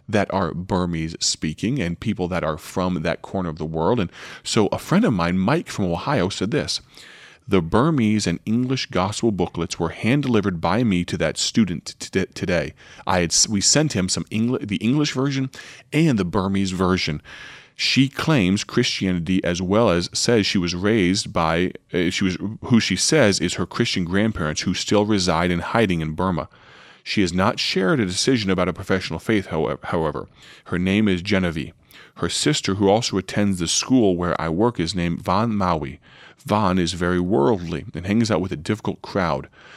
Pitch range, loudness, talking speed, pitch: 85-105 Hz, -21 LUFS, 185 wpm, 95 Hz